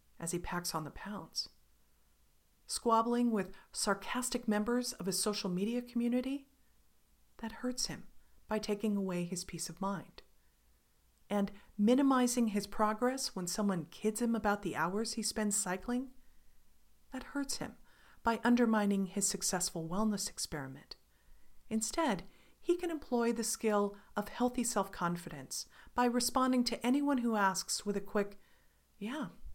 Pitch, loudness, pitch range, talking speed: 210 Hz, -35 LUFS, 190-240 Hz, 140 wpm